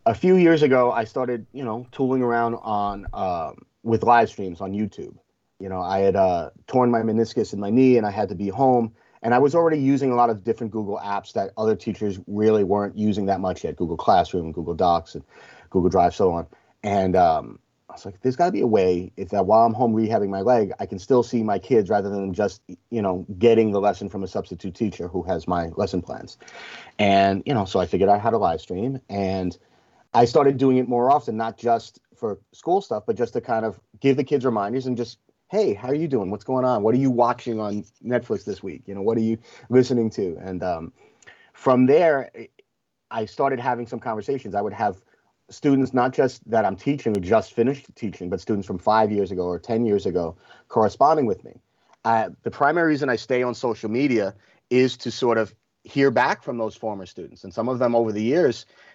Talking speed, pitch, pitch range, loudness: 230 wpm, 115 Hz, 100-125 Hz, -22 LUFS